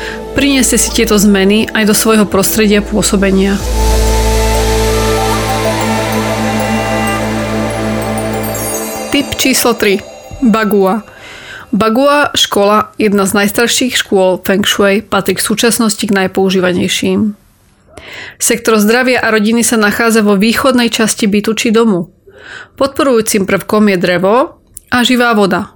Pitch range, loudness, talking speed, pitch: 175-230 Hz, -11 LUFS, 105 wpm, 205 Hz